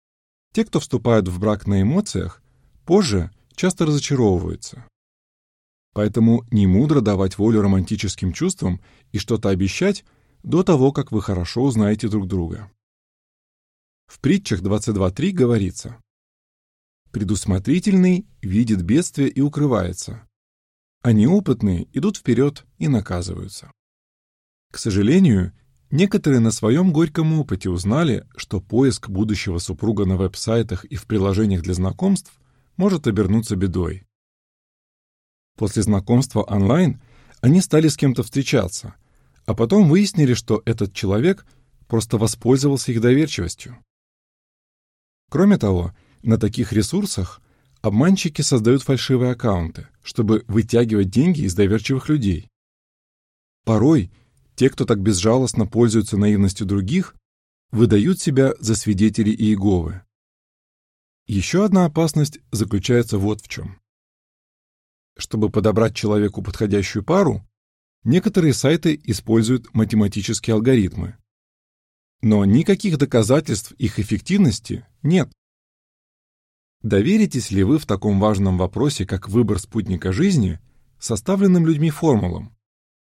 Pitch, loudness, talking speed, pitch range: 110 Hz, -19 LUFS, 105 wpm, 100-135 Hz